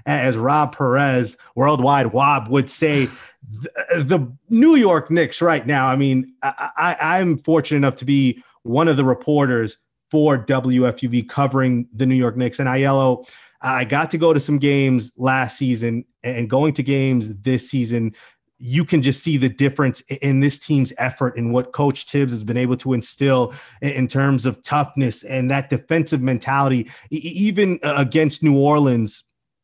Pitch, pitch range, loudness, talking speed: 135 Hz, 125-145 Hz, -19 LUFS, 170 wpm